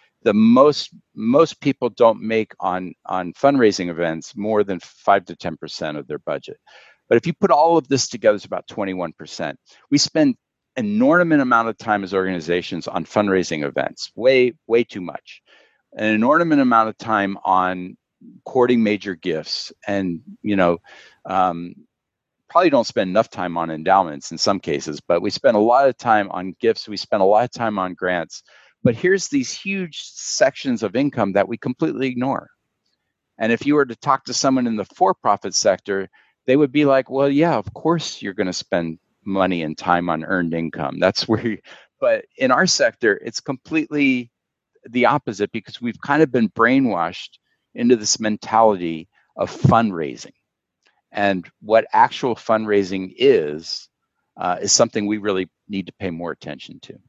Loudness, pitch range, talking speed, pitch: -19 LUFS, 95-140 Hz, 175 wpm, 110 Hz